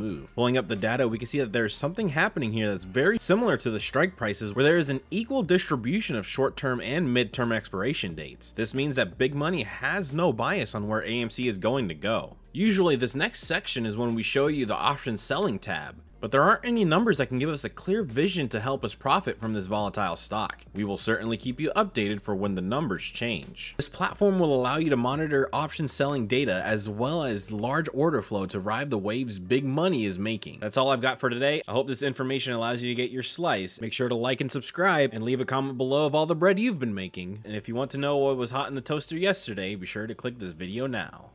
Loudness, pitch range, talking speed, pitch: -27 LUFS, 110-150 Hz, 250 wpm, 130 Hz